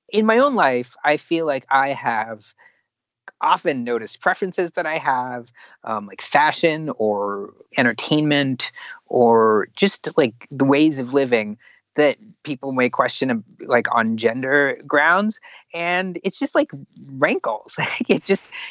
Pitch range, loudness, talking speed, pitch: 125-185 Hz, -20 LUFS, 135 wpm, 145 Hz